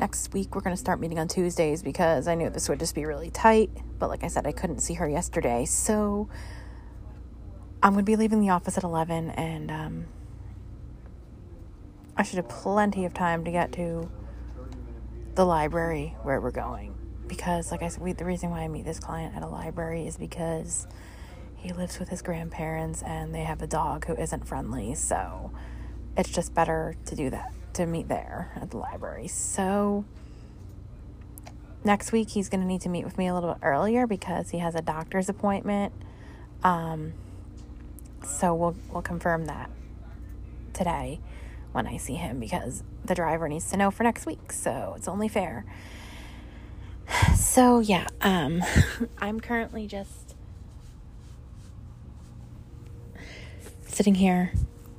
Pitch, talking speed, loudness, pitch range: 170 Hz, 160 wpm, -28 LUFS, 135-190 Hz